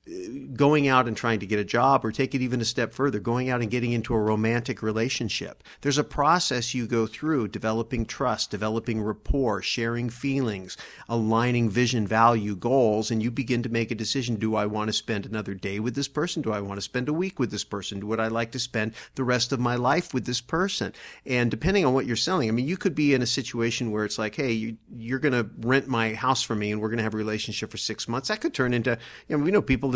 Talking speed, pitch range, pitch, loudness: 250 wpm, 110-130 Hz, 120 Hz, -26 LUFS